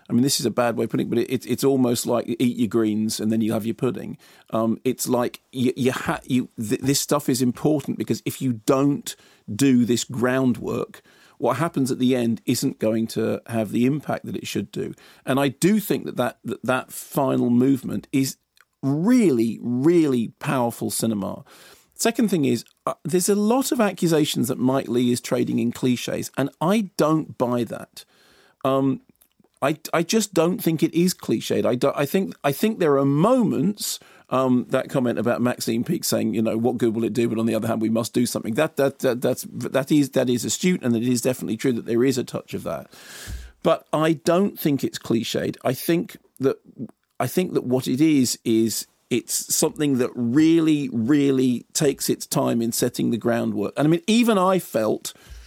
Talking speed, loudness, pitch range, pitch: 210 wpm, -22 LUFS, 120-155 Hz, 130 Hz